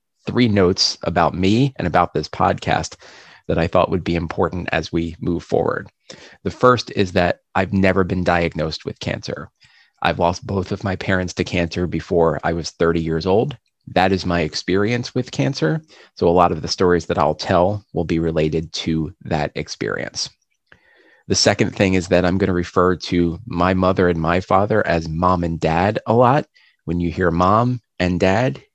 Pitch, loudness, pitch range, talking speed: 90 Hz, -19 LUFS, 85-100 Hz, 190 wpm